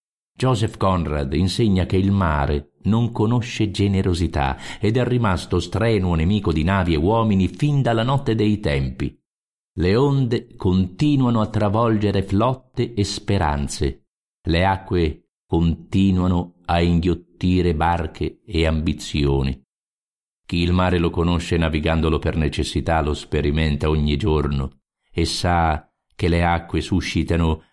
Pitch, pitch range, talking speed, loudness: 90 Hz, 80-105 Hz, 125 wpm, -21 LUFS